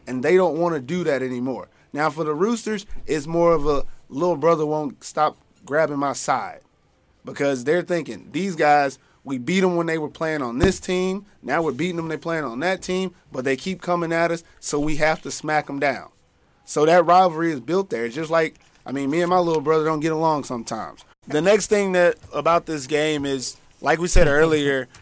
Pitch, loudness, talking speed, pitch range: 155 Hz, -22 LUFS, 225 wpm, 140-175 Hz